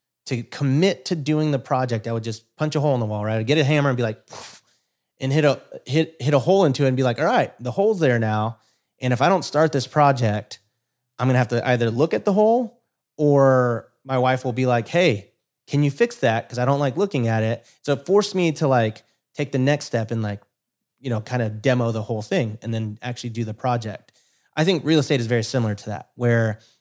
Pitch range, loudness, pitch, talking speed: 115-145 Hz, -21 LUFS, 125 Hz, 250 wpm